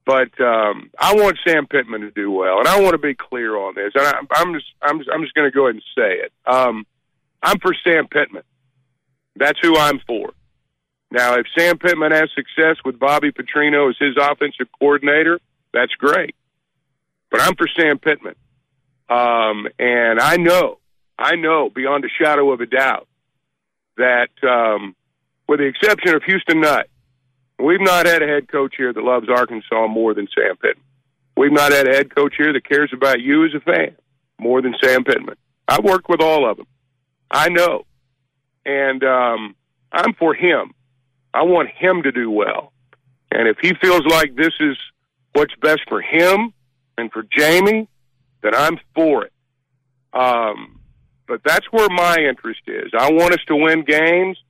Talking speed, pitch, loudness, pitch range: 180 wpm, 140 Hz, -16 LUFS, 130-160 Hz